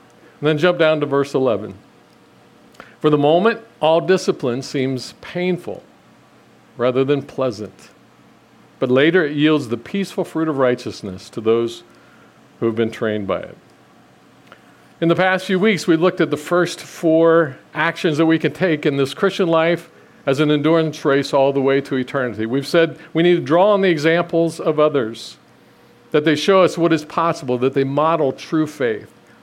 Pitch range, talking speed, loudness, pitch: 135-170 Hz, 175 wpm, -18 LUFS, 155 Hz